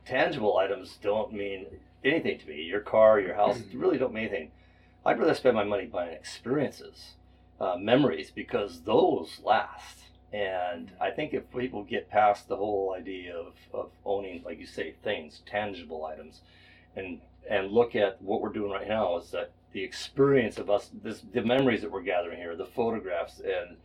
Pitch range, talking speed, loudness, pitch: 100-120 Hz, 180 wpm, -29 LUFS, 105 Hz